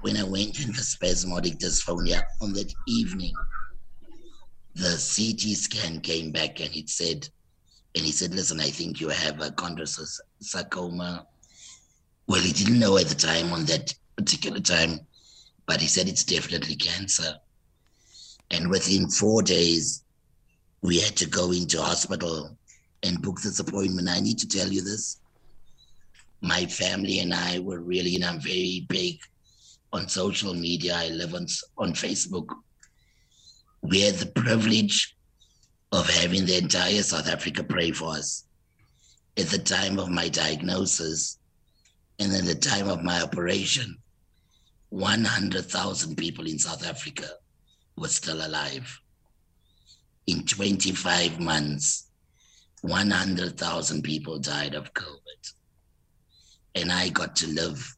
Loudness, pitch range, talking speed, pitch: -25 LUFS, 80-95 Hz, 135 wpm, 90 Hz